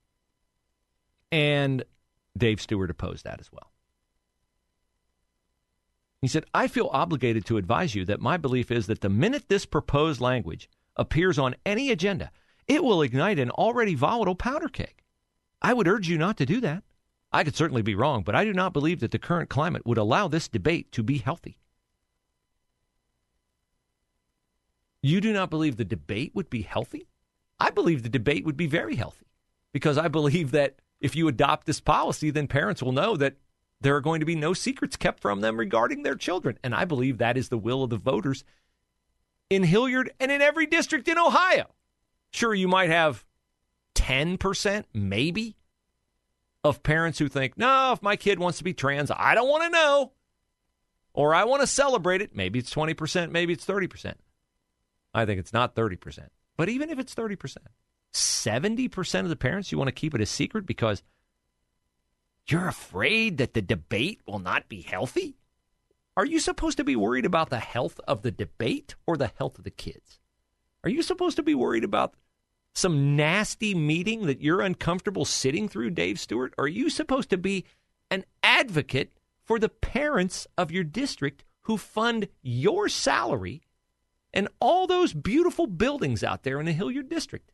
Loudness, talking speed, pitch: -26 LUFS, 175 wpm, 155 Hz